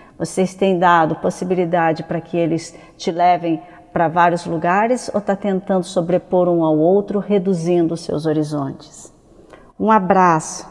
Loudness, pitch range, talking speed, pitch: -17 LUFS, 165-190 Hz, 140 wpm, 175 Hz